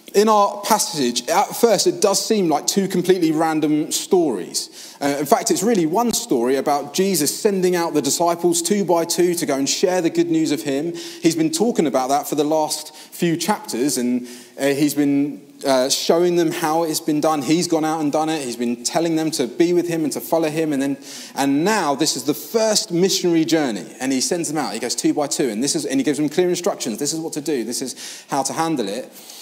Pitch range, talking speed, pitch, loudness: 145-185 Hz, 240 wpm, 160 Hz, -19 LUFS